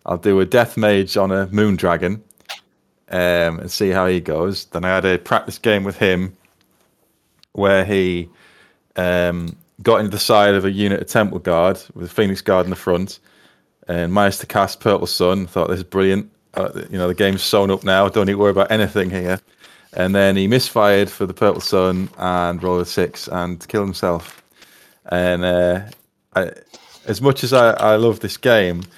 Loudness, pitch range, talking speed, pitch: -18 LUFS, 90-100 Hz, 195 wpm, 95 Hz